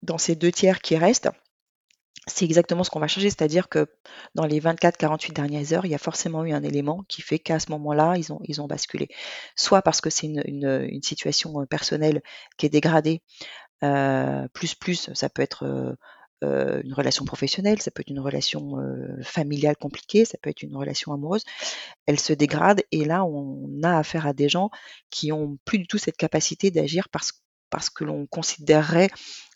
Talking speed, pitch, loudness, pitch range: 195 wpm, 155 Hz, -24 LUFS, 145-175 Hz